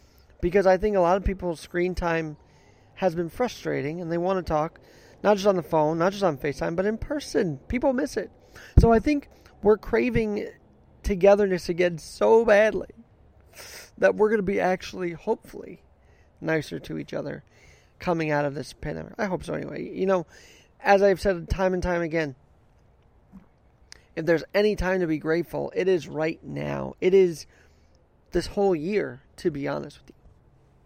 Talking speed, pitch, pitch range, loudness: 175 wpm, 180 Hz, 155-200 Hz, -25 LUFS